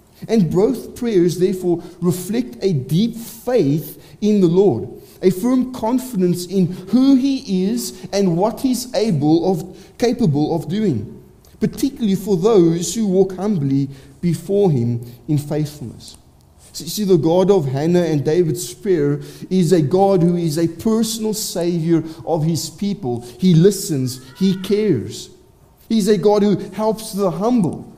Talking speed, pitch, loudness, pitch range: 140 wpm, 185 Hz, -18 LUFS, 165-210 Hz